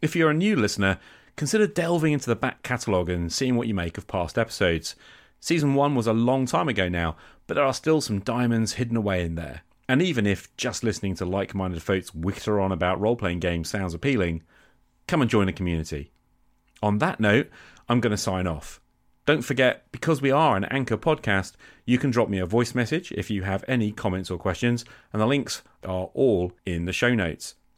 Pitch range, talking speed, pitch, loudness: 90-125 Hz, 210 wpm, 105 Hz, -25 LUFS